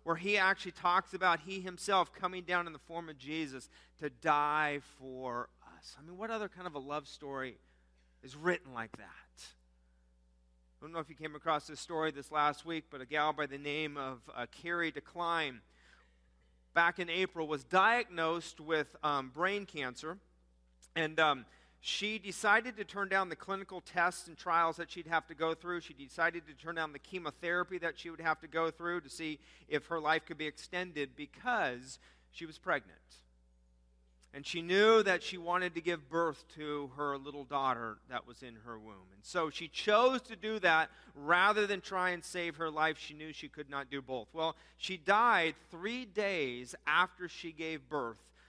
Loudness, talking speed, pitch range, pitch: -35 LUFS, 190 wpm, 140-175 Hz, 160 Hz